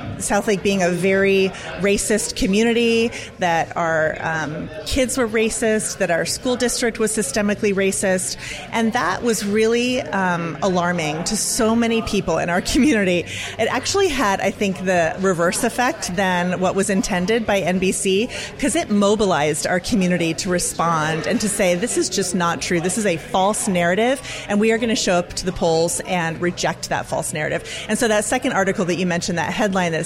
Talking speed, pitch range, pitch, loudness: 185 wpm, 175-225 Hz, 195 Hz, -19 LUFS